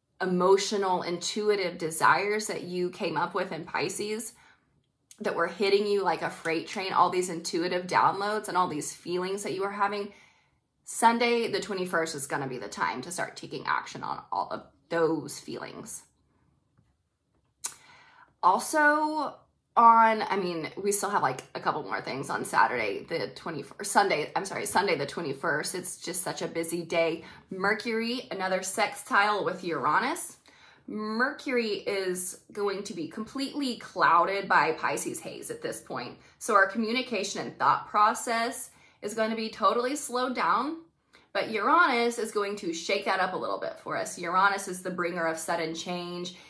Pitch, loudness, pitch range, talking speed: 200 Hz, -28 LUFS, 180-230 Hz, 165 wpm